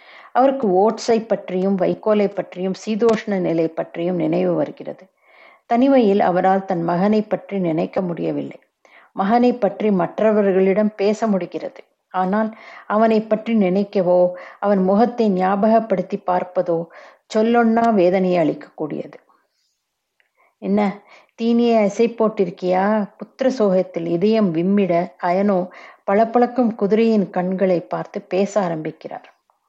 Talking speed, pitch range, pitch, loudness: 95 wpm, 180-220 Hz, 200 Hz, -19 LUFS